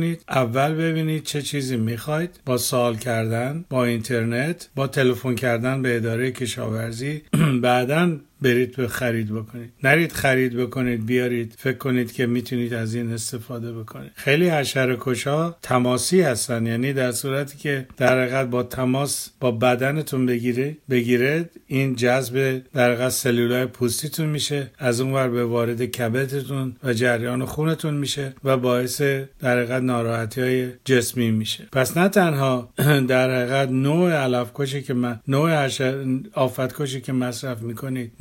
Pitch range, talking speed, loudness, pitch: 120-140 Hz, 135 wpm, -22 LUFS, 130 Hz